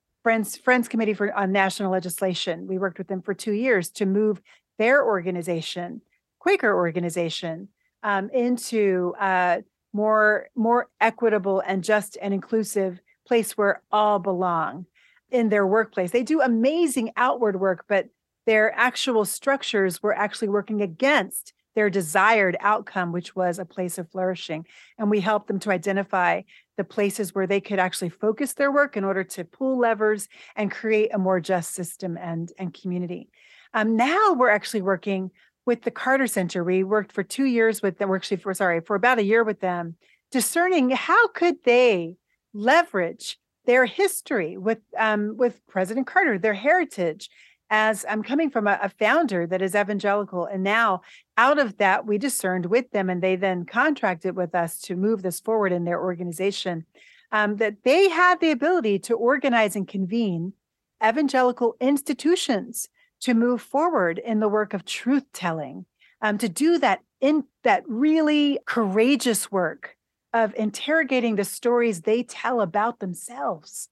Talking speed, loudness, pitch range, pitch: 160 wpm, -23 LUFS, 190-240 Hz, 210 Hz